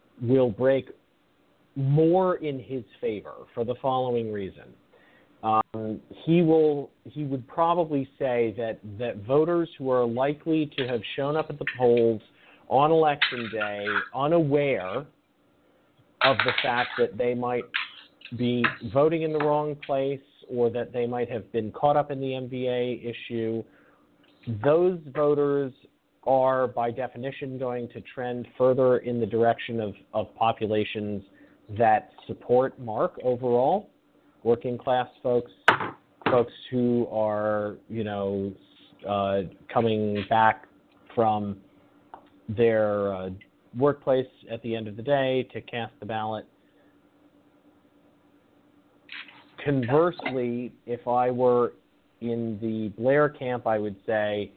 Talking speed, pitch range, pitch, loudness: 125 wpm, 110-135 Hz, 120 Hz, -26 LUFS